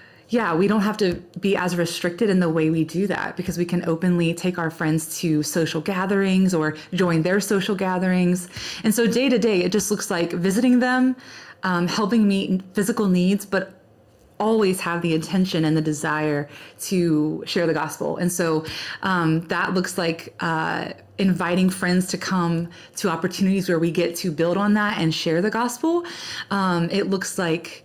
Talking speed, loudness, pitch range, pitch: 185 wpm, -22 LUFS, 165-200 Hz, 180 Hz